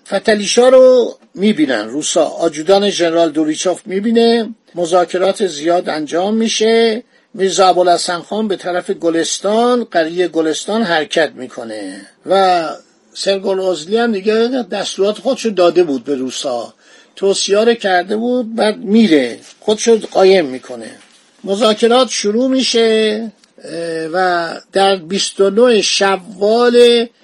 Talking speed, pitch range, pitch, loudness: 105 wpm, 175-230 Hz, 195 Hz, -14 LUFS